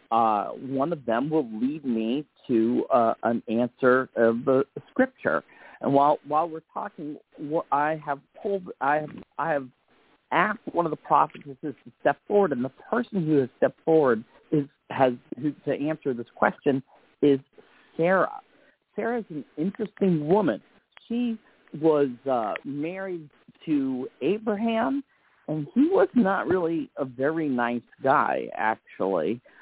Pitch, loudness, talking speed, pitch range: 150 Hz, -26 LUFS, 145 wpm, 135-190 Hz